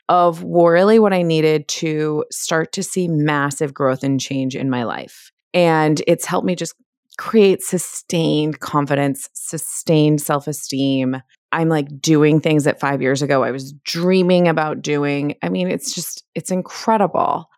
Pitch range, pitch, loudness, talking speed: 140-175 Hz, 155 Hz, -18 LUFS, 155 wpm